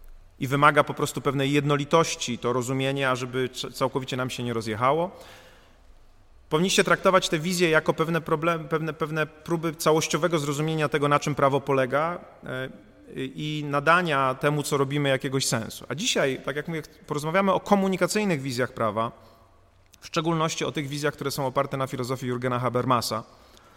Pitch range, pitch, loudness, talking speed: 125-160 Hz, 140 Hz, -25 LUFS, 150 wpm